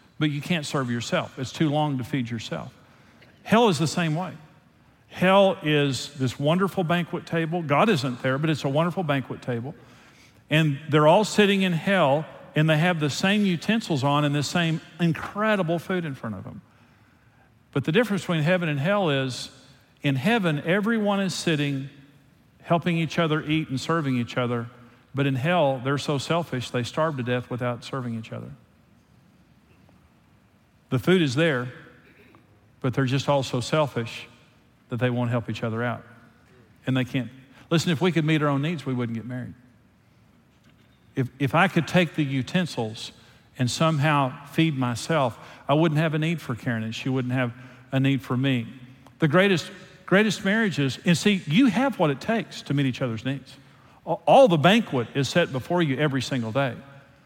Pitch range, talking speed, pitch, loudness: 125-170 Hz, 180 wpm, 145 Hz, -24 LUFS